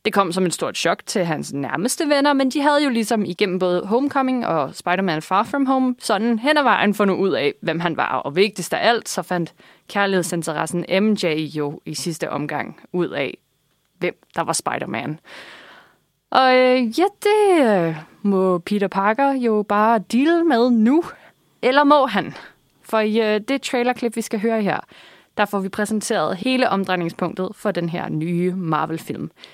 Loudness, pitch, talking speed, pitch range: -20 LUFS, 205 Hz, 175 wpm, 175-250 Hz